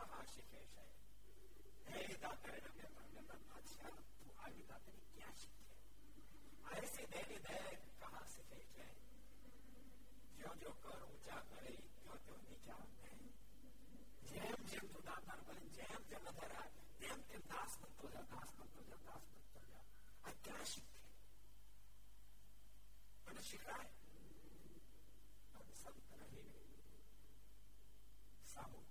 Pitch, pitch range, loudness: 105 Hz, 100-110 Hz, -57 LUFS